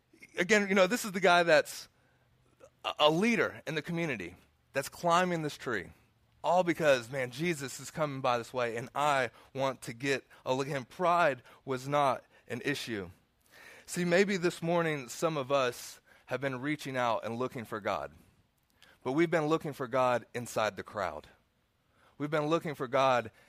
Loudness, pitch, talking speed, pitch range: -31 LUFS, 140 Hz, 175 wpm, 125-170 Hz